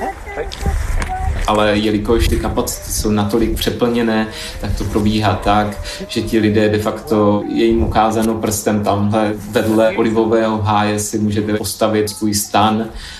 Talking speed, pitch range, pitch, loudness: 130 wpm, 105-110 Hz, 105 Hz, -16 LUFS